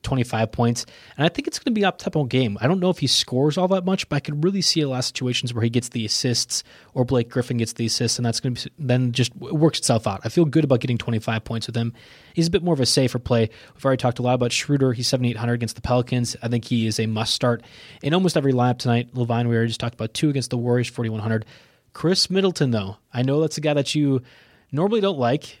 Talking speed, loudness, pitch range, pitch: 275 wpm, -22 LUFS, 115-150 Hz, 125 Hz